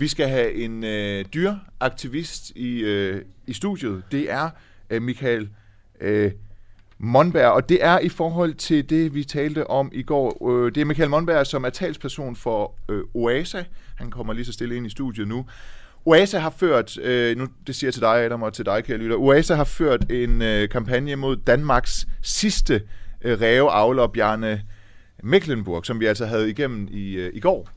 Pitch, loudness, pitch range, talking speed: 120 Hz, -22 LUFS, 105-145 Hz, 185 wpm